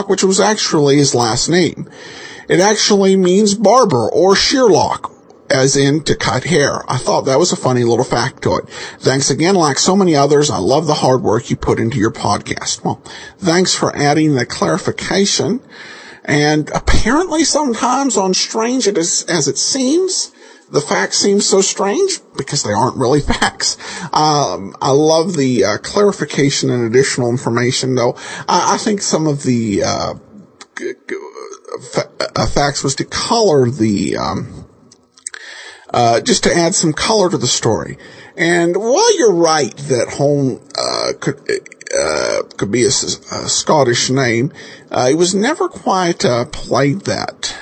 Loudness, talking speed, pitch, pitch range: -14 LUFS, 155 wpm, 175 Hz, 140-230 Hz